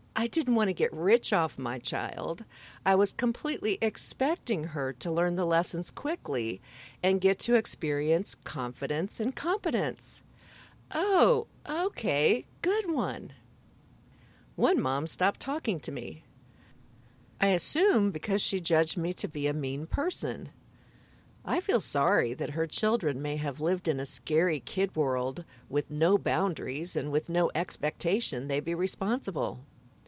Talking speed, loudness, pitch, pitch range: 140 wpm, -30 LUFS, 170 Hz, 140-220 Hz